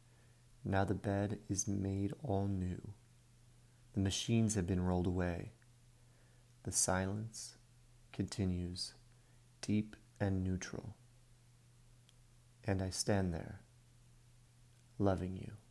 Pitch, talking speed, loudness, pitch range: 115 Hz, 95 wpm, -38 LUFS, 100-120 Hz